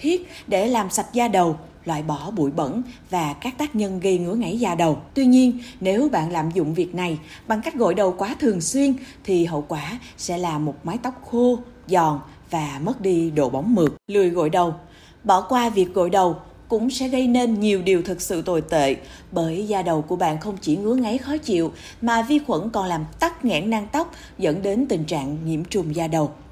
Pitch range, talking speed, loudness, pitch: 165-240 Hz, 215 wpm, -22 LUFS, 190 Hz